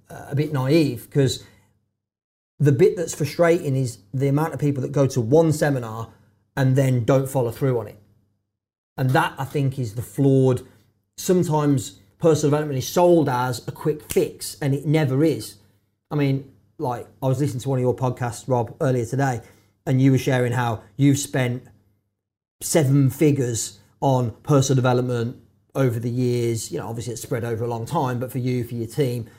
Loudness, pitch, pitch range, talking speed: -22 LUFS, 130 Hz, 115-140 Hz, 180 wpm